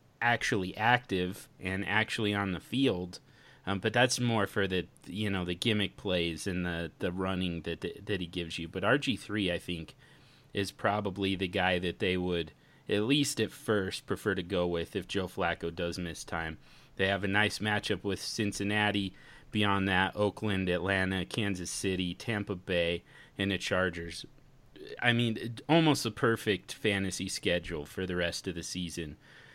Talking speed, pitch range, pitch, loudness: 170 wpm, 90-105 Hz, 95 Hz, -32 LUFS